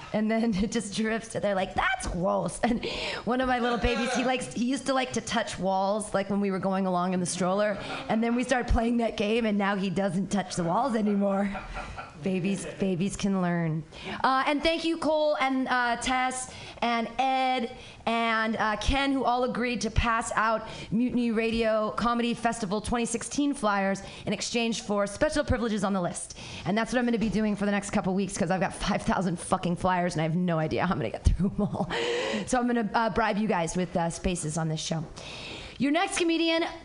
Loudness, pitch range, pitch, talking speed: -28 LUFS, 190-240 Hz, 215 Hz, 220 wpm